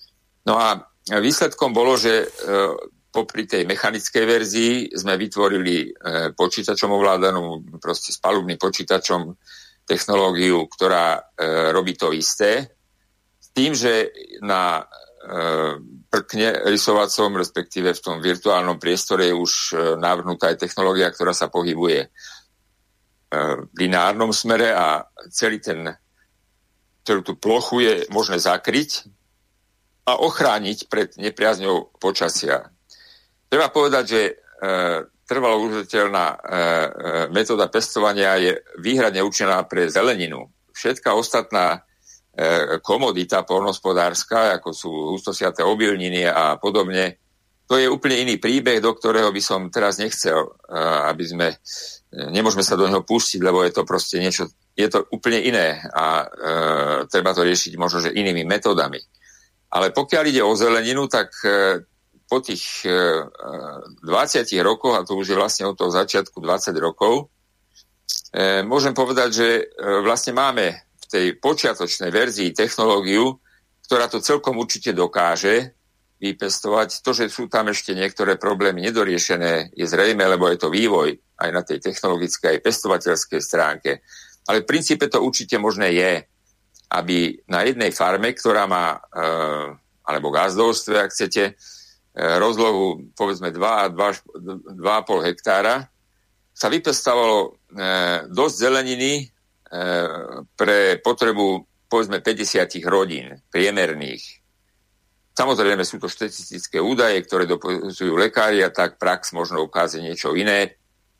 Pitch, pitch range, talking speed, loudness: 100 Hz, 90-110 Hz, 120 wpm, -20 LUFS